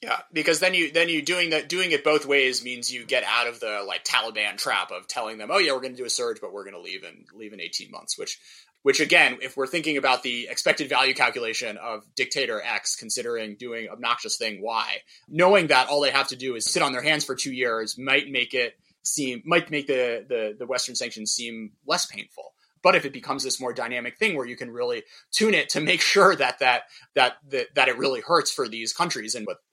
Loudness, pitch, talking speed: -23 LUFS, 150 Hz, 235 wpm